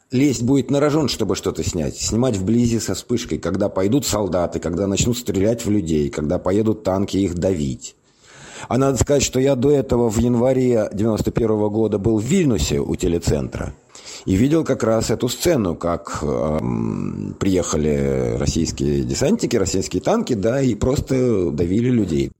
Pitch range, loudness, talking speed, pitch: 90-125 Hz, -19 LUFS, 155 wpm, 110 Hz